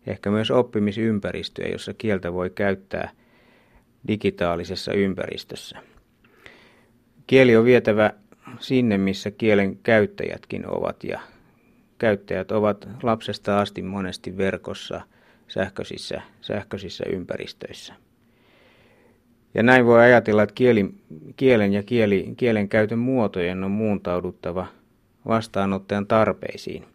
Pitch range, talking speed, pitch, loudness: 100-120 Hz, 95 wpm, 105 Hz, -22 LUFS